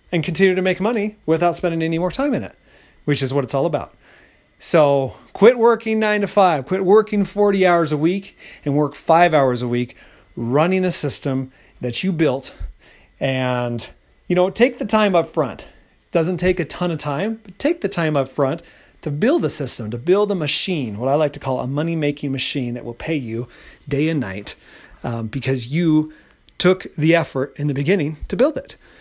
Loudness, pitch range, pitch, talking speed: -19 LUFS, 135-185 Hz, 155 Hz, 205 wpm